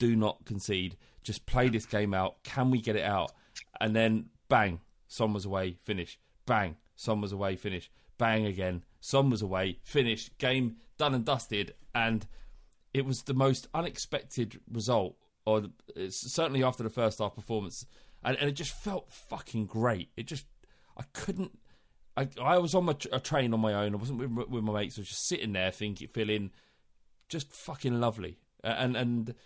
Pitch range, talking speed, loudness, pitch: 100-130 Hz, 180 wpm, -32 LUFS, 115 Hz